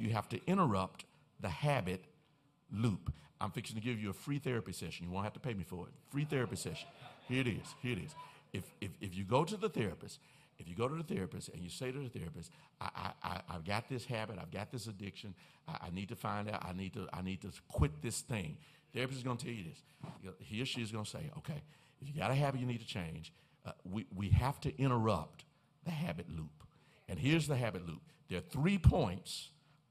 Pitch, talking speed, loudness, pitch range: 120 Hz, 245 wpm, -39 LUFS, 95-145 Hz